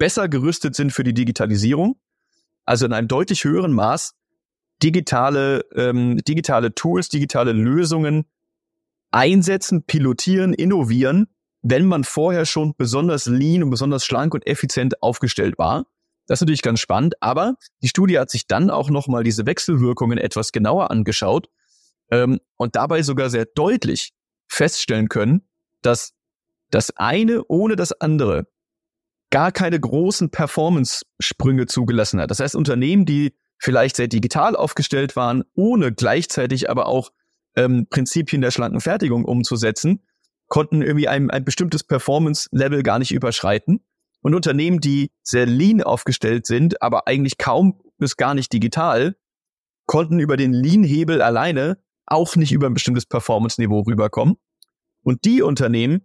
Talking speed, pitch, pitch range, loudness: 140 wpm, 140 Hz, 125-170 Hz, -19 LUFS